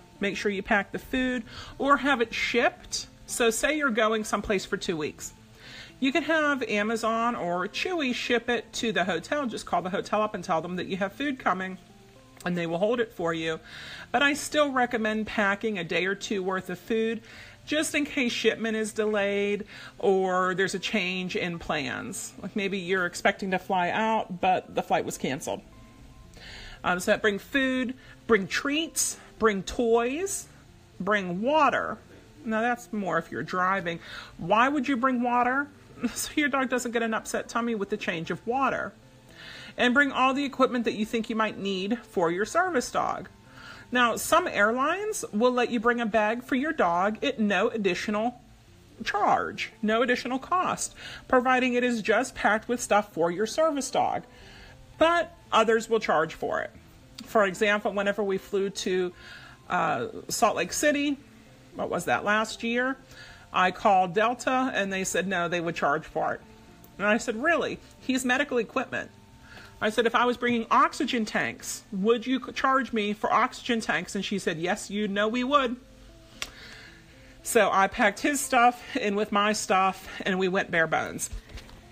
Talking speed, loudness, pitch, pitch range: 175 wpm, -26 LUFS, 220 Hz, 195-250 Hz